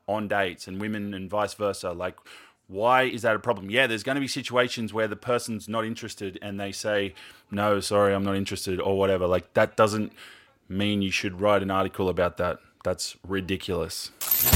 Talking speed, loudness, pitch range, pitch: 190 wpm, -26 LUFS, 95-110 Hz, 100 Hz